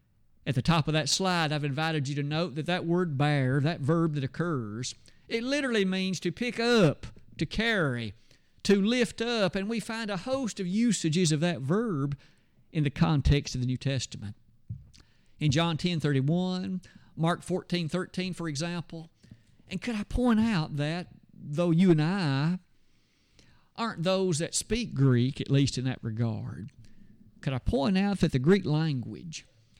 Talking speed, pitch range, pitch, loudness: 170 wpm, 135-185 Hz, 165 Hz, -28 LUFS